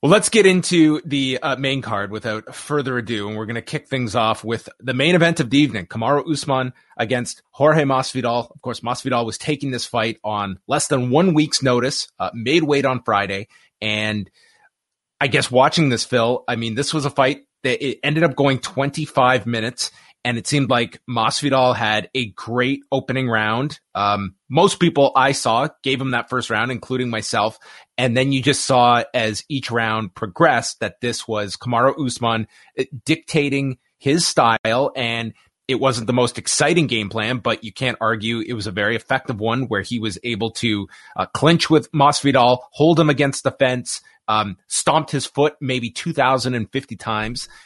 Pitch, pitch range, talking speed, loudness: 125 Hz, 115-140 Hz, 185 wpm, -19 LUFS